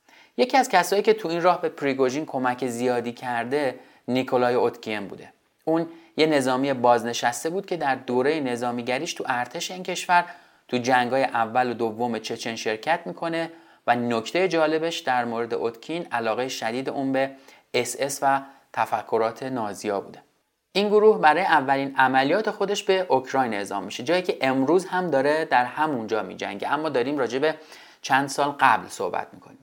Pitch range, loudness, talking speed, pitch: 125-165 Hz, -24 LUFS, 160 wpm, 135 Hz